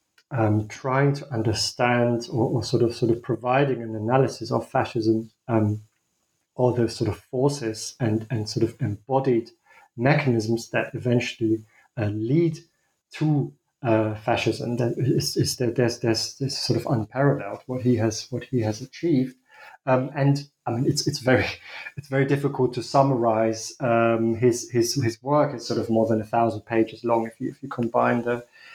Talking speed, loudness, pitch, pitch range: 175 wpm, -24 LUFS, 120 Hz, 110-130 Hz